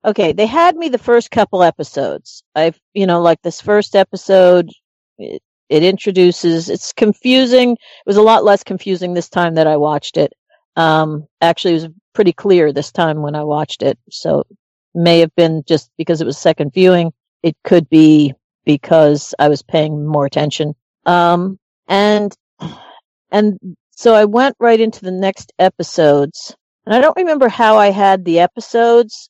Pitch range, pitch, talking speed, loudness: 155-210 Hz, 175 Hz, 170 wpm, -13 LUFS